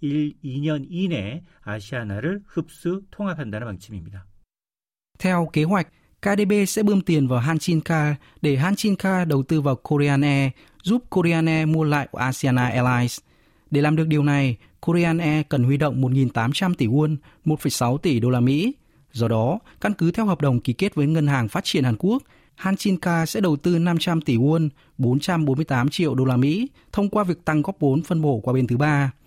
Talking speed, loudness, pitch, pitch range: 180 wpm, -22 LUFS, 150 Hz, 130-175 Hz